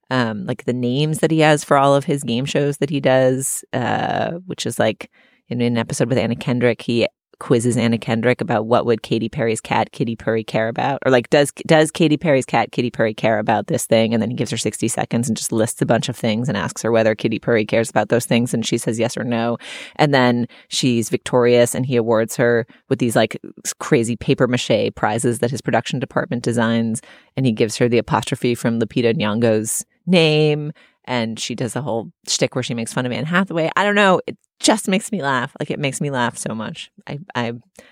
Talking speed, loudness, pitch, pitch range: 230 wpm, -19 LUFS, 125 Hz, 115-145 Hz